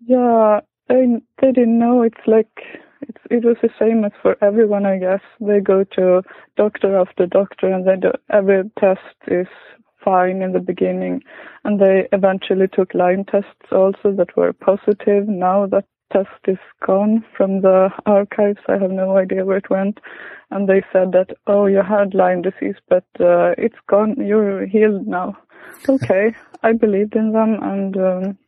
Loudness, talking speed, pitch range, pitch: -17 LUFS, 170 wpm, 190-220 Hz, 200 Hz